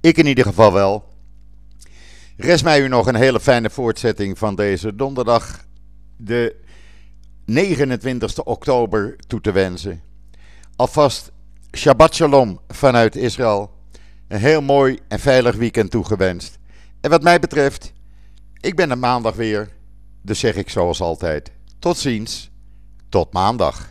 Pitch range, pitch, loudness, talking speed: 90-135 Hz, 110 Hz, -17 LUFS, 130 wpm